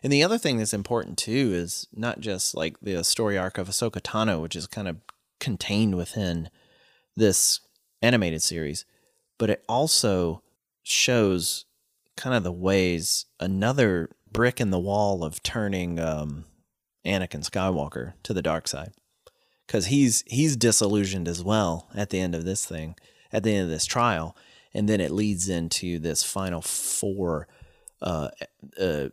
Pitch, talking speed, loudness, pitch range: 95 Hz, 155 wpm, -25 LUFS, 85-110 Hz